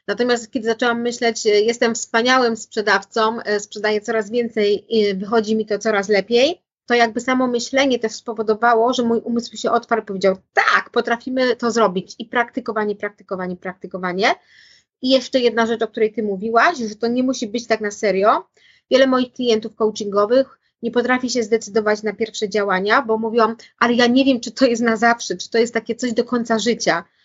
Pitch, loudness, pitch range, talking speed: 230 Hz, -19 LUFS, 215-240 Hz, 185 wpm